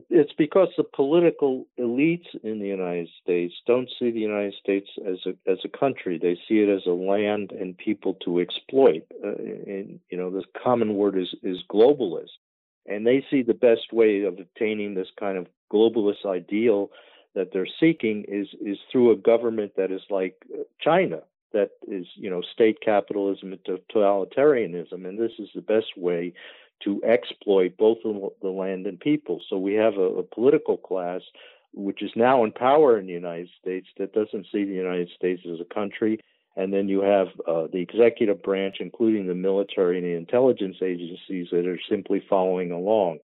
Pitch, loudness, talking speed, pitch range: 100 Hz, -24 LUFS, 180 wpm, 90-115 Hz